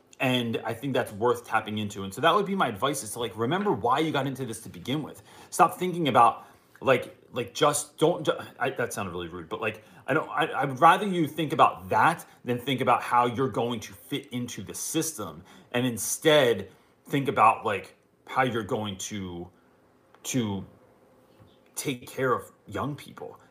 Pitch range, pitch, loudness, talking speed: 105-140 Hz, 125 Hz, -27 LUFS, 190 wpm